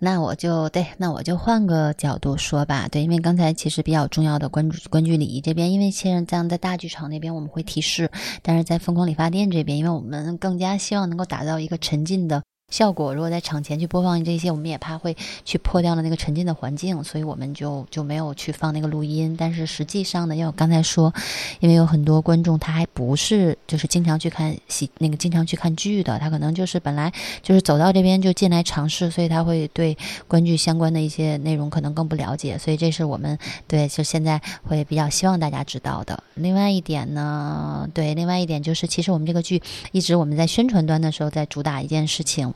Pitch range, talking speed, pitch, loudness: 150-175 Hz, 355 characters per minute, 160 Hz, -22 LUFS